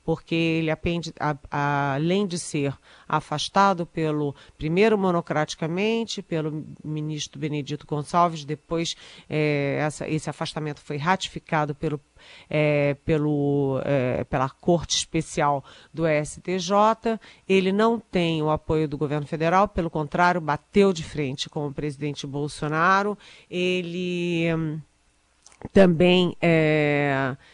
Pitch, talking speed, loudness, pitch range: 155 Hz, 115 wpm, -24 LUFS, 150-175 Hz